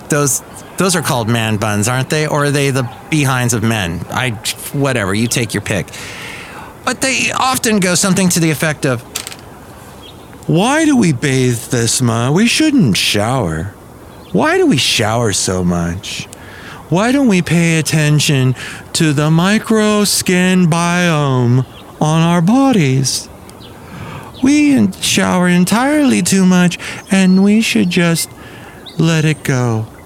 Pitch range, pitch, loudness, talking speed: 120-185 Hz, 155 Hz, -13 LUFS, 140 wpm